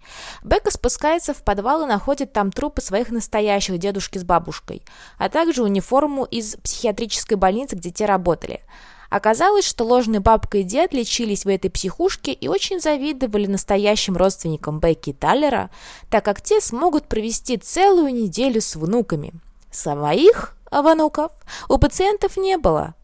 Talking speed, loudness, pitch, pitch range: 145 wpm, -19 LUFS, 230 Hz, 195-300 Hz